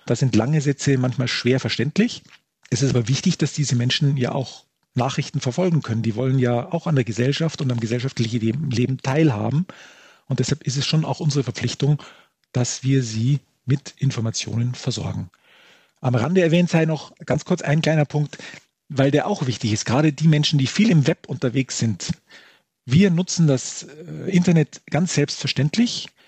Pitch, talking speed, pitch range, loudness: 140 Hz, 170 wpm, 125-155 Hz, -21 LUFS